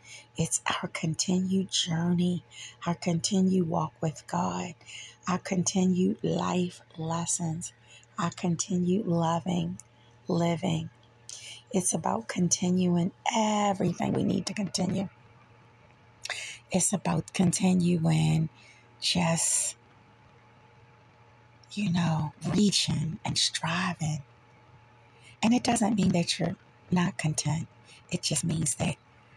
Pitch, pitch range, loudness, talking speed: 165 Hz, 120-180 Hz, -28 LUFS, 95 wpm